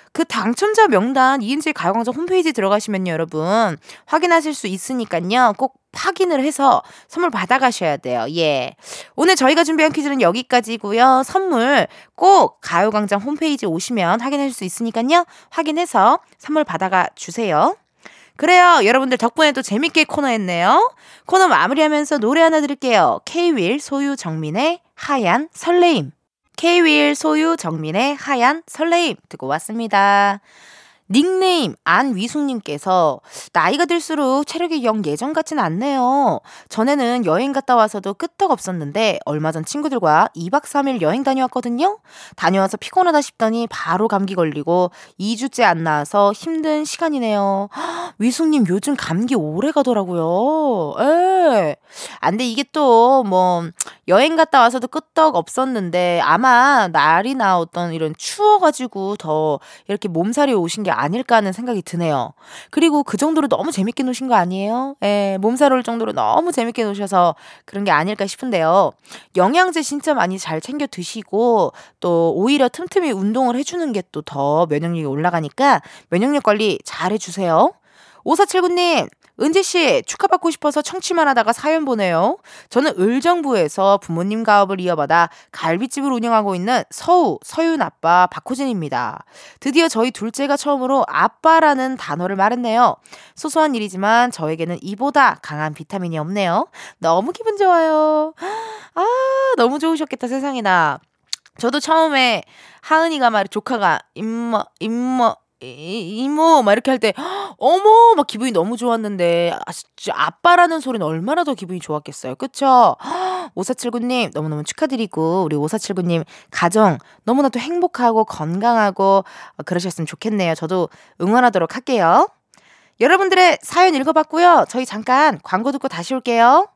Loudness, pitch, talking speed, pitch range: -17 LUFS, 245 Hz, 325 characters per minute, 195-310 Hz